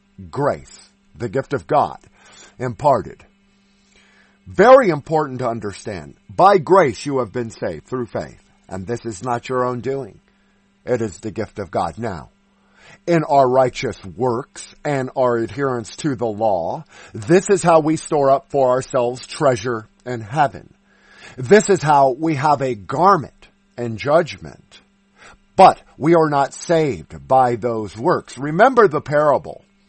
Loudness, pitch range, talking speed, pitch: -18 LUFS, 120-160 Hz, 145 wpm, 130 Hz